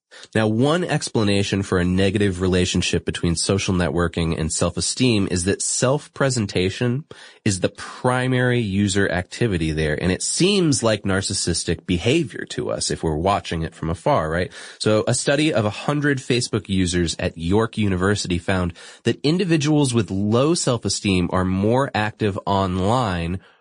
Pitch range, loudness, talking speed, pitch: 90-125 Hz, -21 LUFS, 145 wpm, 100 Hz